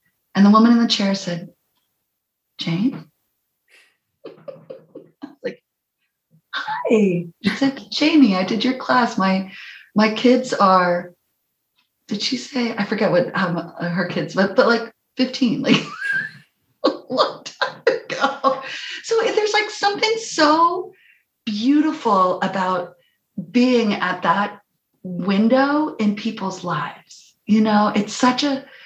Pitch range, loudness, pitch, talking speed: 190-275 Hz, -19 LUFS, 225 Hz, 125 wpm